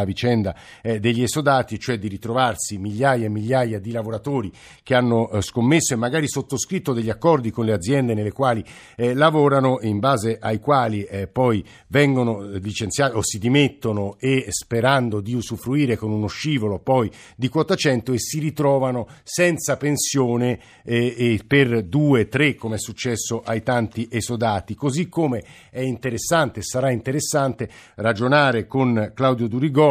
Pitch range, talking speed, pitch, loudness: 110-135 Hz, 145 wpm, 120 Hz, -21 LUFS